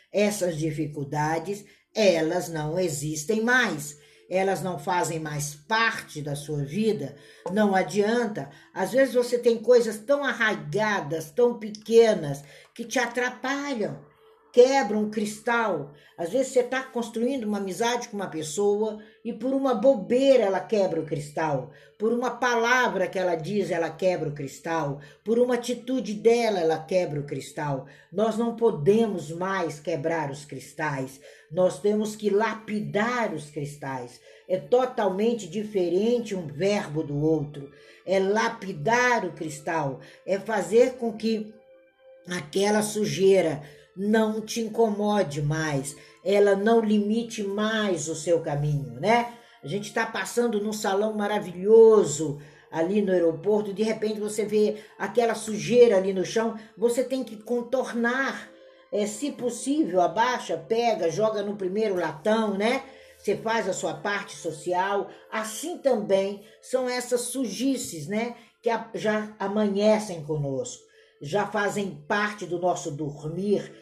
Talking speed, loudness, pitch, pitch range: 135 wpm, -25 LUFS, 205 Hz, 170-230 Hz